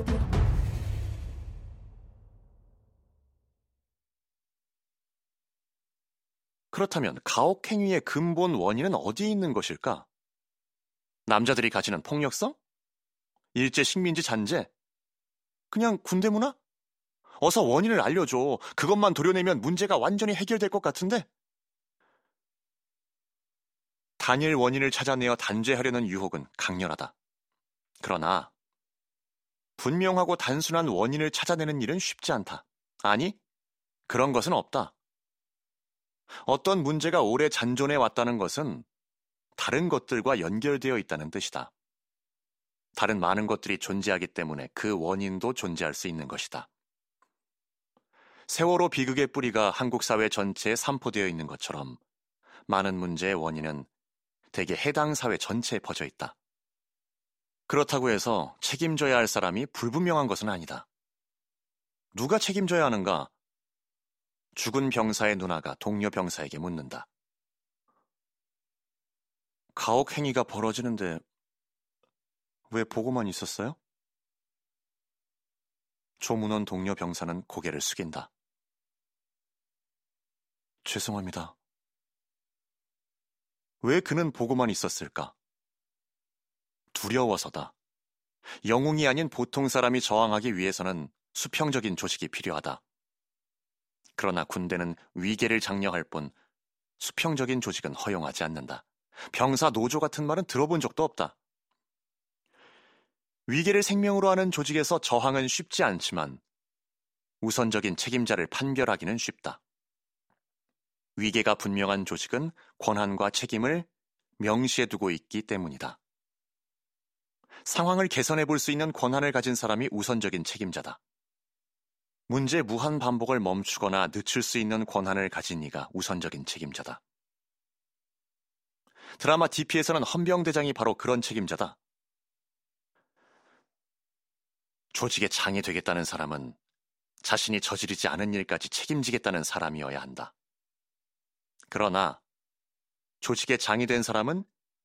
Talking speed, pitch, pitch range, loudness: 245 characters per minute, 120 Hz, 100-150 Hz, -28 LUFS